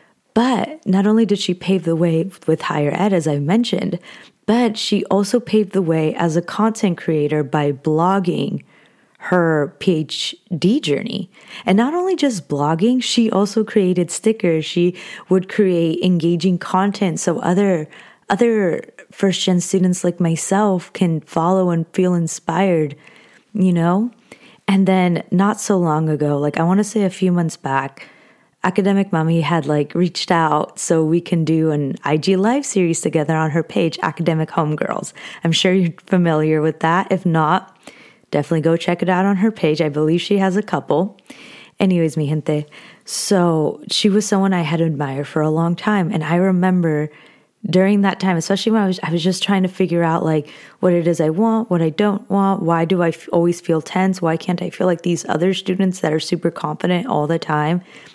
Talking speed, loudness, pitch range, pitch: 185 wpm, -18 LUFS, 160-195 Hz, 180 Hz